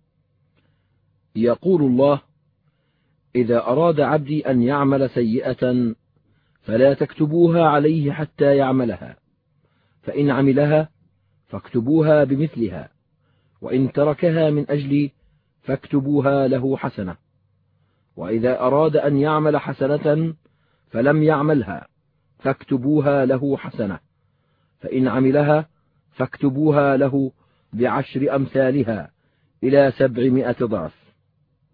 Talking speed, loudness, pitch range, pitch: 80 wpm, -19 LUFS, 130-150 Hz, 140 Hz